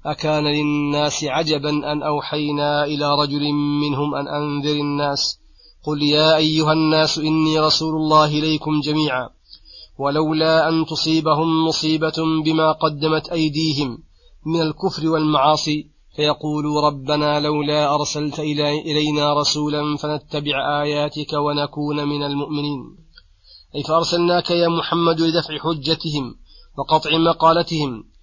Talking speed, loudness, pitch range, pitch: 105 wpm, -19 LUFS, 145-155 Hz, 150 Hz